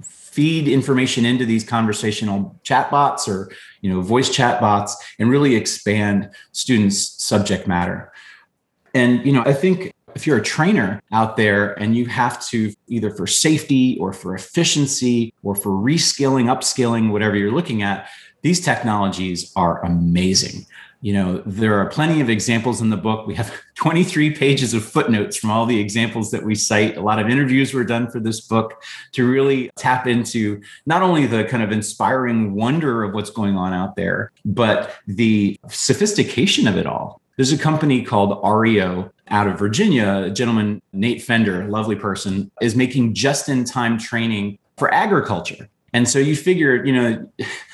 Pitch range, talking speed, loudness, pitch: 105-130 Hz, 170 wpm, -18 LUFS, 115 Hz